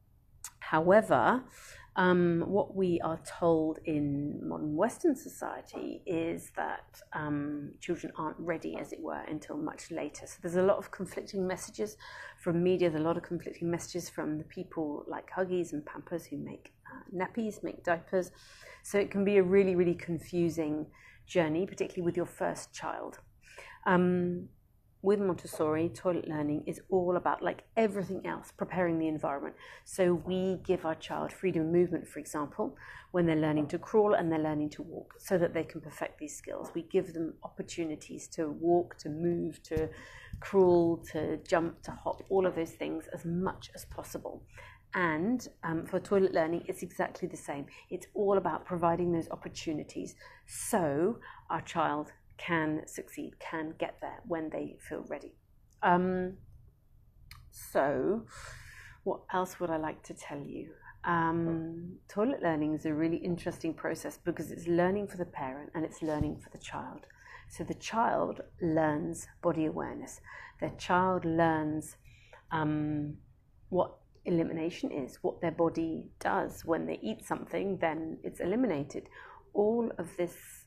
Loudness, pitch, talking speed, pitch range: -33 LUFS, 170 Hz, 155 wpm, 155-185 Hz